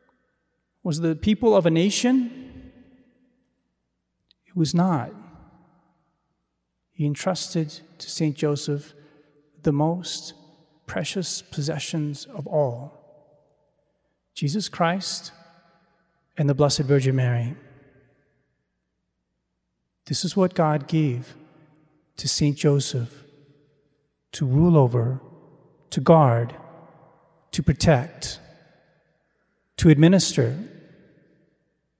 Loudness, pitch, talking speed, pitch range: -23 LUFS, 155 Hz, 85 wpm, 145-170 Hz